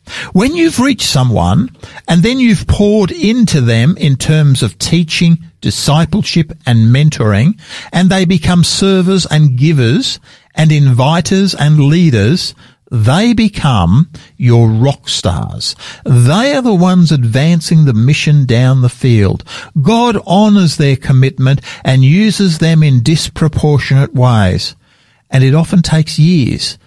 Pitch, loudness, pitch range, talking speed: 155 Hz, -10 LUFS, 130-180 Hz, 125 wpm